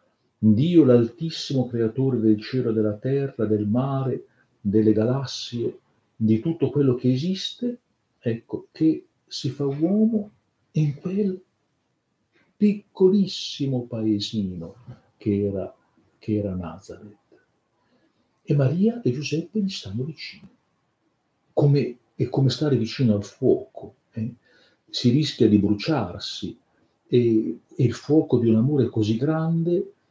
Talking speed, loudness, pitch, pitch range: 115 wpm, -23 LUFS, 130 Hz, 110-160 Hz